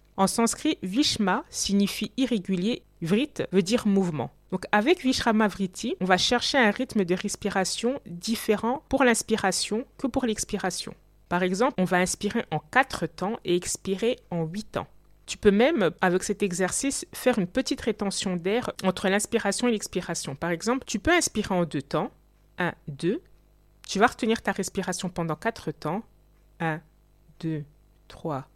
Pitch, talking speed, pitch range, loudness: 200 Hz, 160 wpm, 185-235 Hz, -26 LUFS